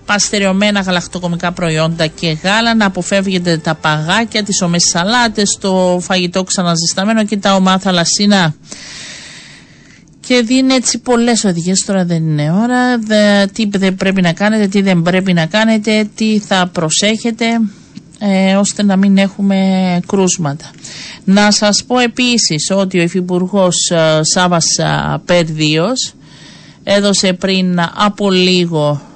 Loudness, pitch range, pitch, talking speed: -12 LUFS, 175-210 Hz, 190 Hz, 125 wpm